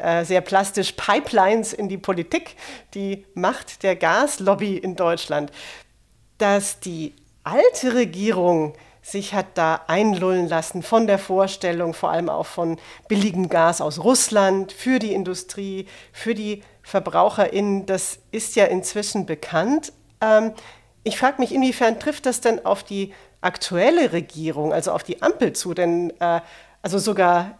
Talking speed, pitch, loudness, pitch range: 135 wpm, 195 Hz, -21 LUFS, 175-215 Hz